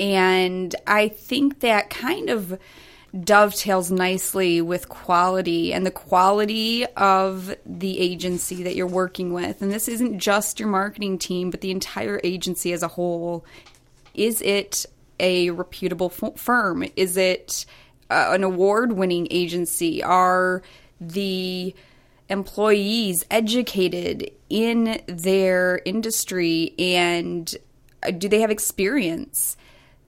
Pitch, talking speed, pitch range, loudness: 185 Hz, 115 wpm, 180-205 Hz, -22 LUFS